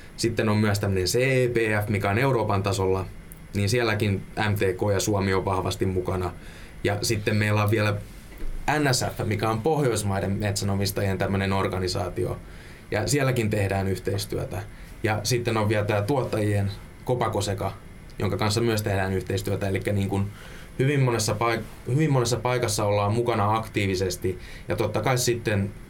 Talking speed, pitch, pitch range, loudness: 135 wpm, 105 Hz, 95-115 Hz, -25 LUFS